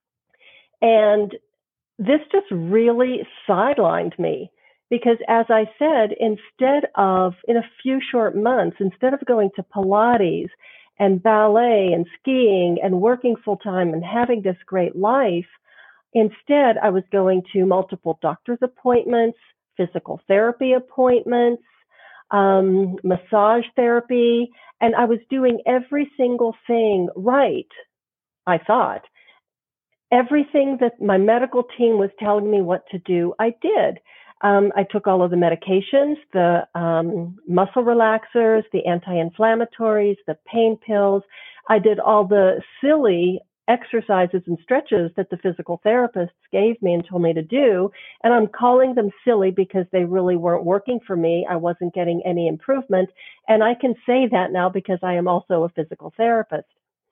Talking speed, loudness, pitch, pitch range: 145 wpm, -19 LUFS, 215 Hz, 185-240 Hz